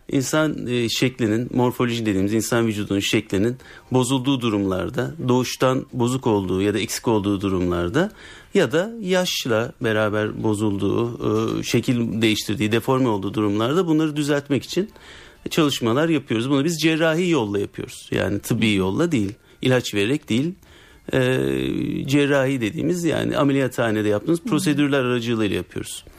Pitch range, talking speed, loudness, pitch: 105-145 Hz, 120 wpm, -21 LUFS, 120 Hz